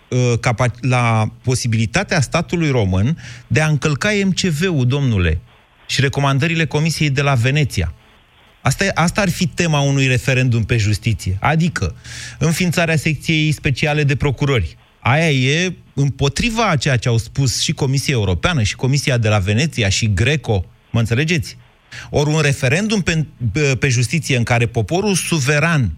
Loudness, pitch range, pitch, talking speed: -17 LUFS, 120-155 Hz, 140 Hz, 140 wpm